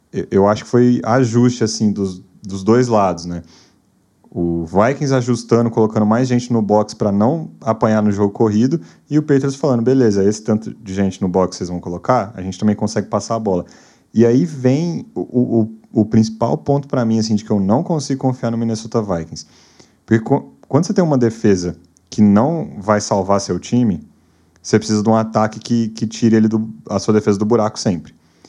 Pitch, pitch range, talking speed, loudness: 110 Hz, 100-120 Hz, 200 wpm, -17 LUFS